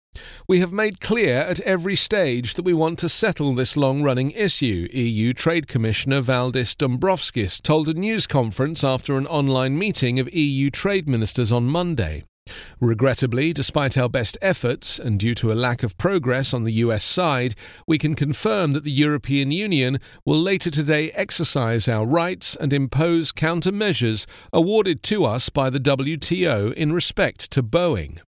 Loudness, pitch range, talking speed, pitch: -20 LUFS, 125-165 Hz, 165 wpm, 140 Hz